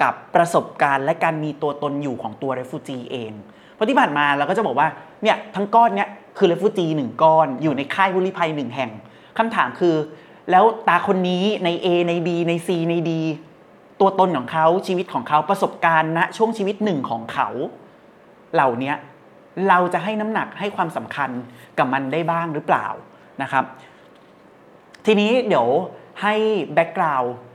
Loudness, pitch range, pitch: -20 LUFS, 145-195 Hz, 170 Hz